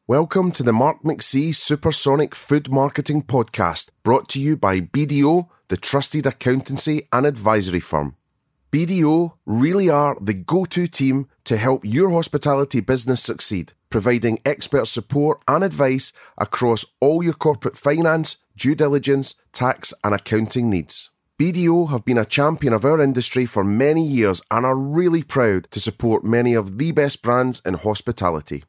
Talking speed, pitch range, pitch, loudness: 155 wpm, 115-150 Hz, 135 Hz, -18 LUFS